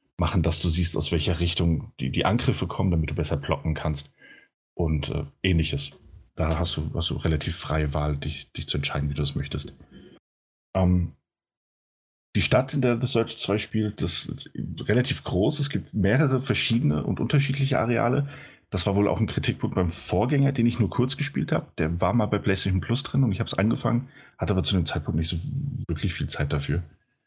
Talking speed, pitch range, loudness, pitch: 200 wpm, 80-120 Hz, -25 LUFS, 95 Hz